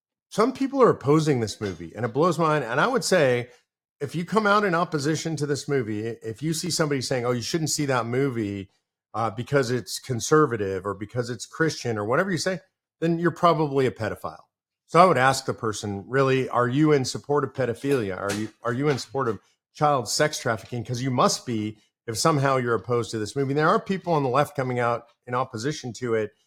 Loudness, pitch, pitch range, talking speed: -24 LUFS, 135 Hz, 115-155 Hz, 225 wpm